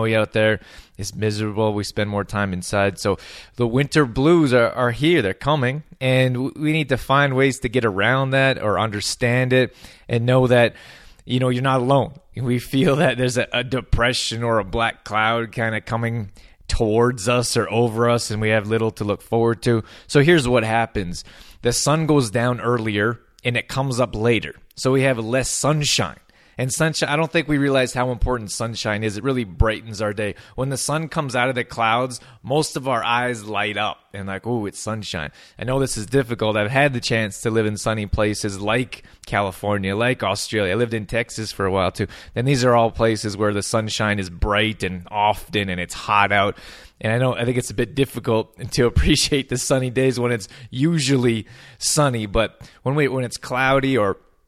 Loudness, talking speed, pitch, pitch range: -20 LUFS, 205 wpm, 120 Hz, 105-130 Hz